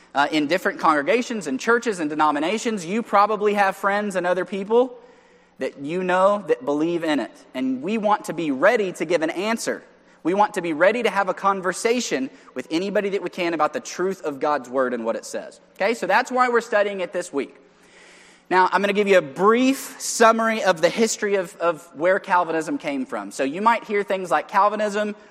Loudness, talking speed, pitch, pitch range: -22 LUFS, 215 wpm, 200 Hz, 175-230 Hz